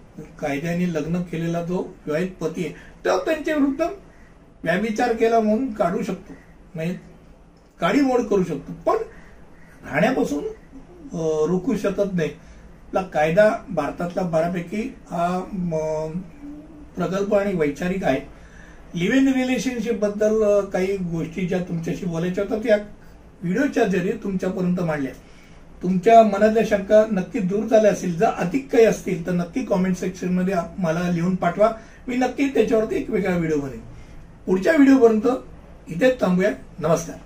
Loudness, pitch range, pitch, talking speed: -22 LUFS, 170-225 Hz, 190 Hz, 125 wpm